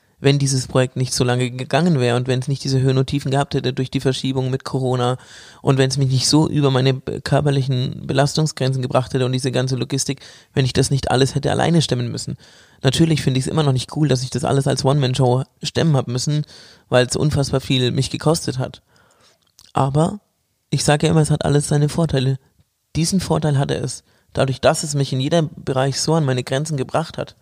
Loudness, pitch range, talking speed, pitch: -19 LUFS, 130-150 Hz, 220 wpm, 135 Hz